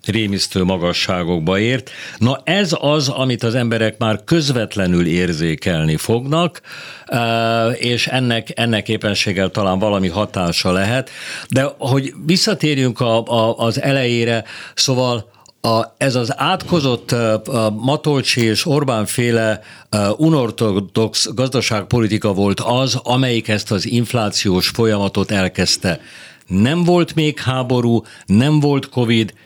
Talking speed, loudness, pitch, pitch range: 115 wpm, -17 LUFS, 115 Hz, 105-130 Hz